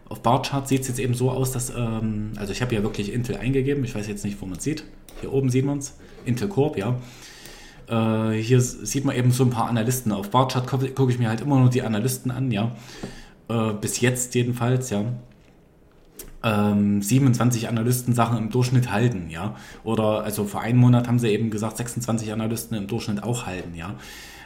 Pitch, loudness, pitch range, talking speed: 120 Hz, -23 LUFS, 105-125 Hz, 205 wpm